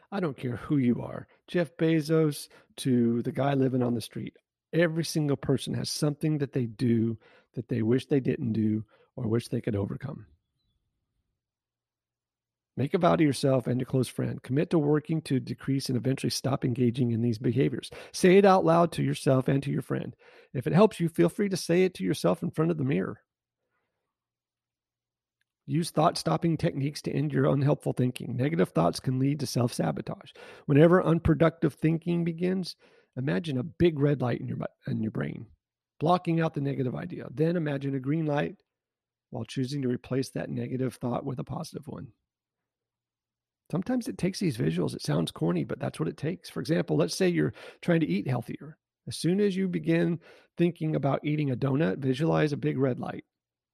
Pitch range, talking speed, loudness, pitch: 125-165 Hz, 190 wpm, -28 LUFS, 140 Hz